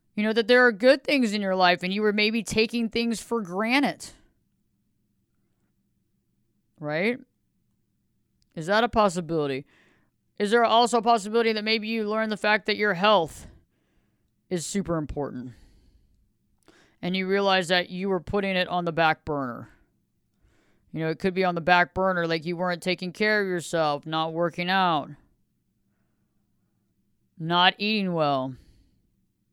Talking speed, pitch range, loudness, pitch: 150 wpm, 135-210 Hz, -24 LUFS, 180 Hz